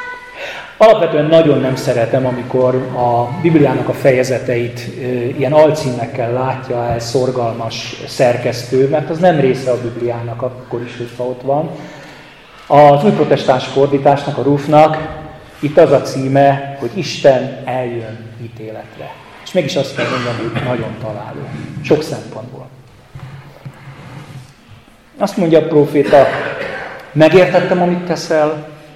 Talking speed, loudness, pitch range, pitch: 115 wpm, -14 LUFS, 125-150 Hz, 135 Hz